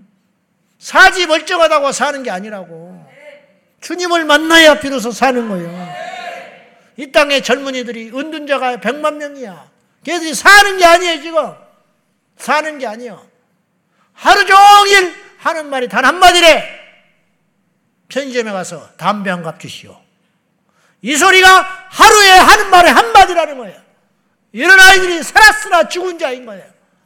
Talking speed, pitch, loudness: 275 characters per minute, 285 Hz, -9 LUFS